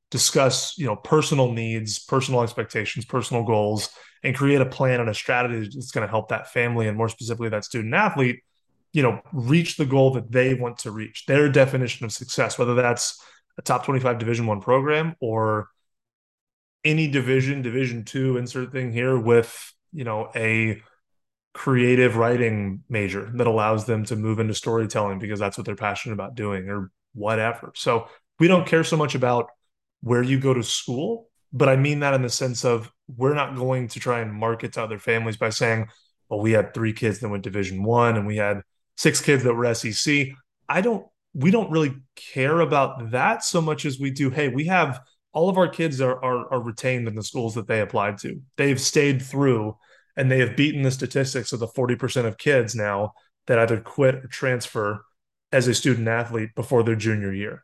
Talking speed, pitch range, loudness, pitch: 200 wpm, 110-135 Hz, -23 LUFS, 120 Hz